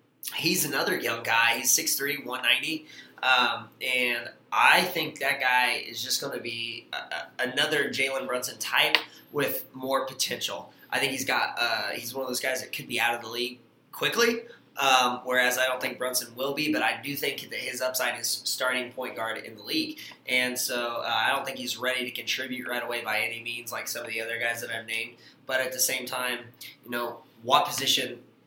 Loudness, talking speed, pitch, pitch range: -27 LUFS, 210 wpm, 125 Hz, 120-135 Hz